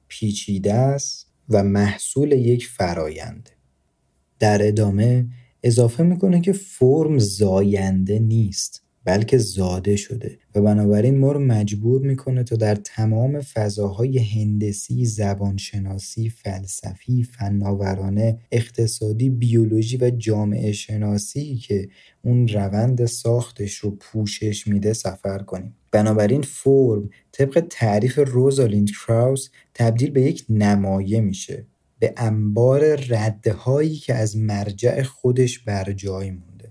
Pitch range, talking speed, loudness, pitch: 100-125 Hz, 110 wpm, -20 LUFS, 110 Hz